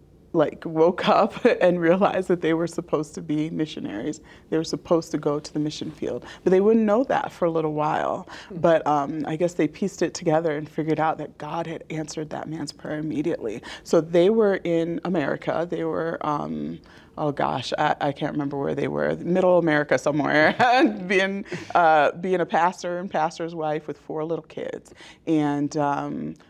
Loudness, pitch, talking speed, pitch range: -23 LUFS, 160 Hz, 190 wpm, 150-180 Hz